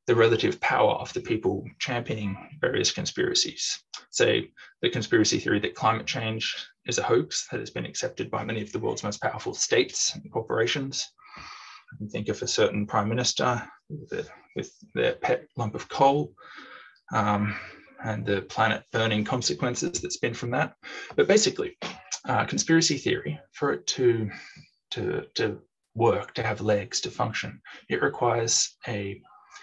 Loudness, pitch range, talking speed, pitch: -27 LUFS, 105-165 Hz, 160 wpm, 120 Hz